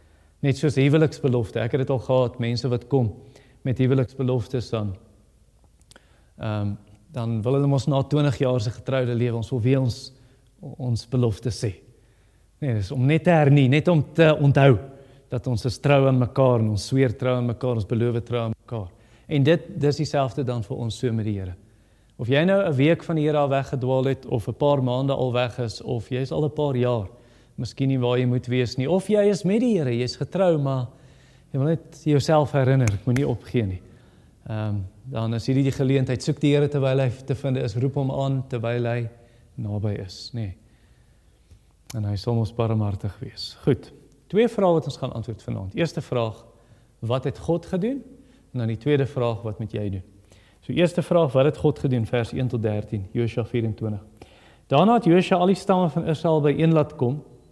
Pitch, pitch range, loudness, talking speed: 125 Hz, 115-140 Hz, -23 LUFS, 205 wpm